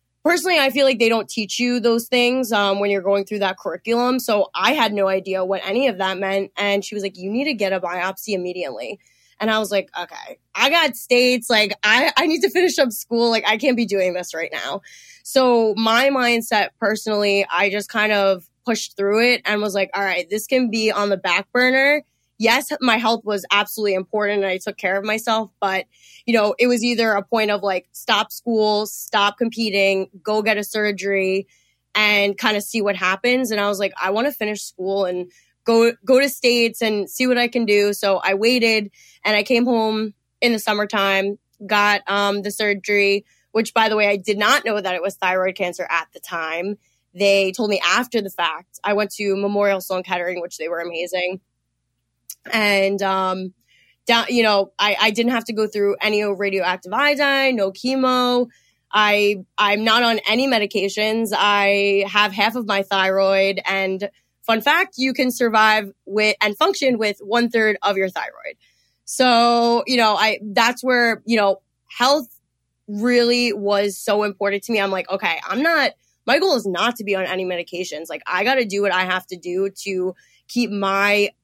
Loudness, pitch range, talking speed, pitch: -19 LUFS, 195-235 Hz, 200 wpm, 210 Hz